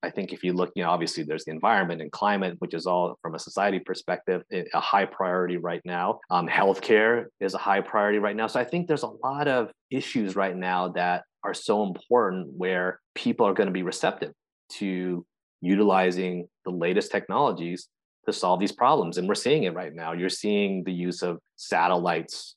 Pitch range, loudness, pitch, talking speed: 90-105 Hz, -26 LUFS, 95 Hz, 200 wpm